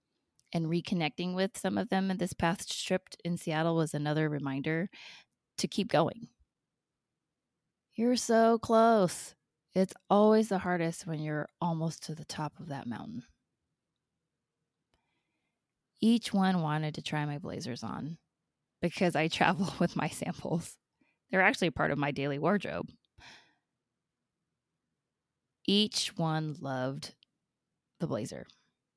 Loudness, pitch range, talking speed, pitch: -31 LUFS, 155-190 Hz, 125 wpm, 170 Hz